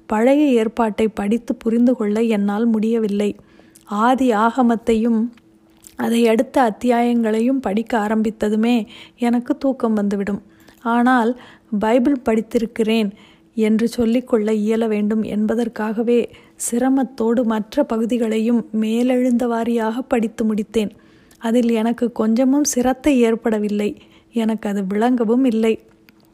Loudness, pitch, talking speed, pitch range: -19 LUFS, 230 Hz, 90 wpm, 220-245 Hz